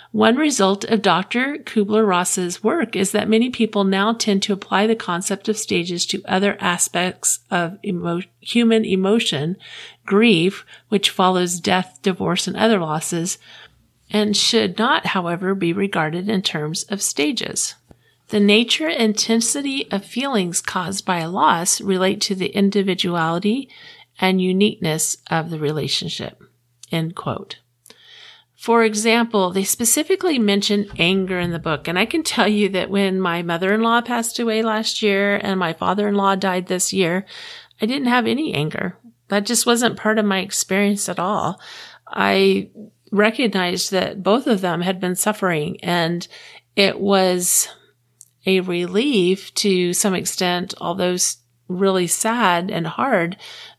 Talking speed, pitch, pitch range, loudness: 145 wpm, 195 Hz, 180-215 Hz, -19 LUFS